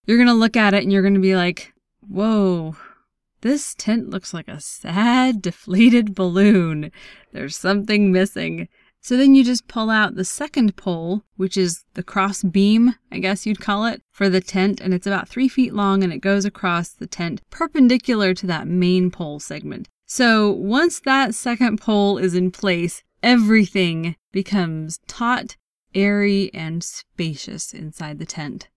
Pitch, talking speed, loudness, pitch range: 195 Hz, 165 wpm, -19 LUFS, 180-225 Hz